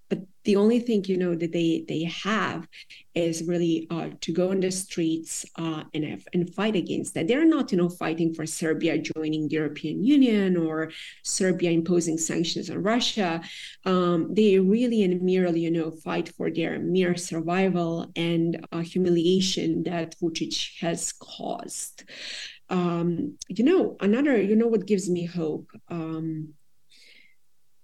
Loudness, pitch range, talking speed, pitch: -25 LUFS, 165-190 Hz, 155 wpm, 175 Hz